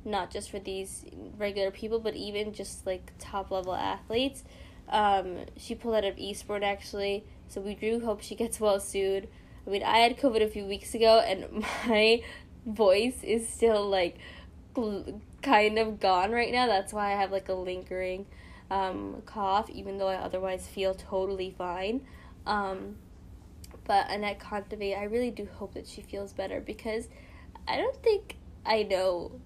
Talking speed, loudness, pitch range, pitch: 170 wpm, -30 LUFS, 190-220 Hz, 200 Hz